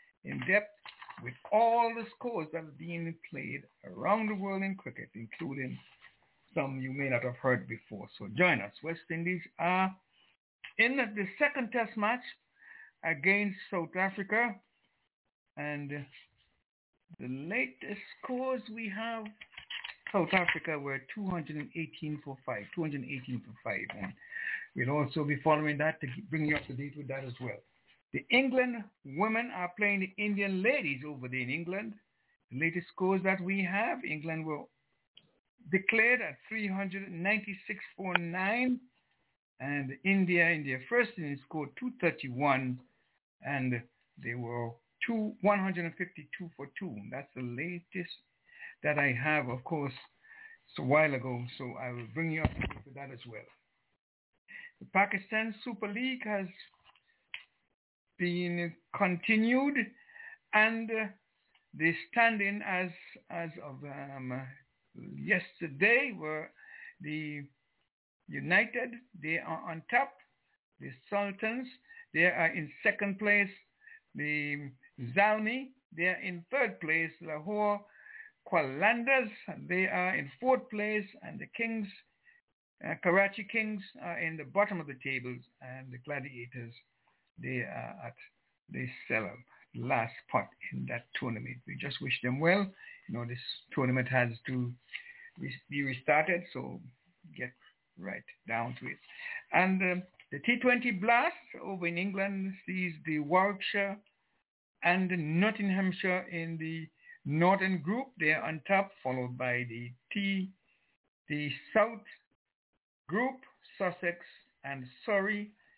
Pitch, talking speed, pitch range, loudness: 180 Hz, 130 wpm, 145-215 Hz, -32 LUFS